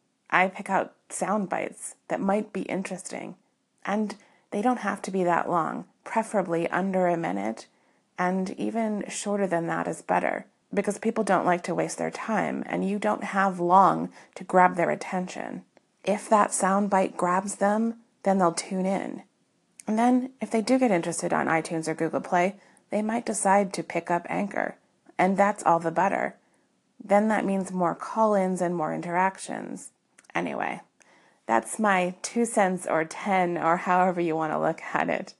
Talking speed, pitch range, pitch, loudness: 175 wpm, 175-205 Hz, 190 Hz, -26 LUFS